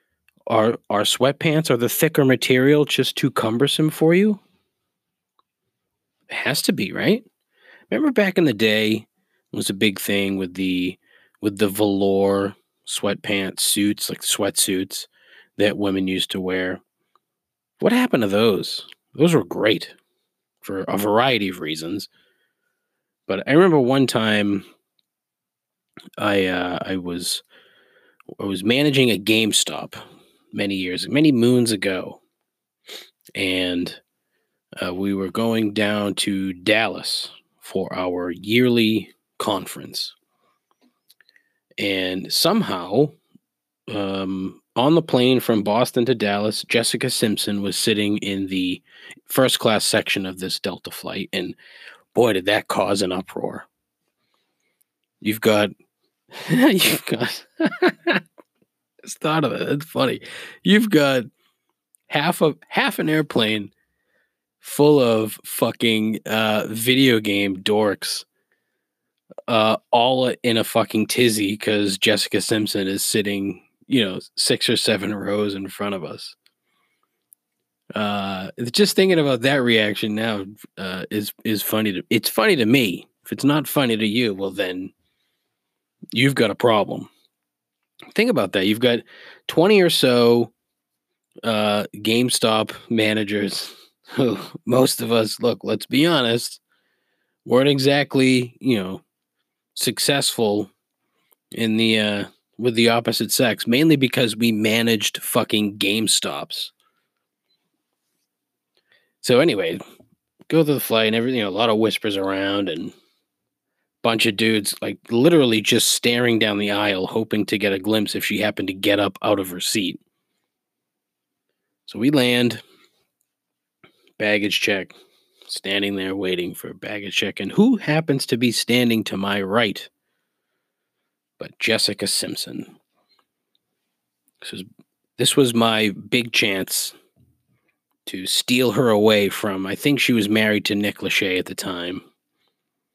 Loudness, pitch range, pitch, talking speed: -20 LUFS, 100-125 Hz, 110 Hz, 130 wpm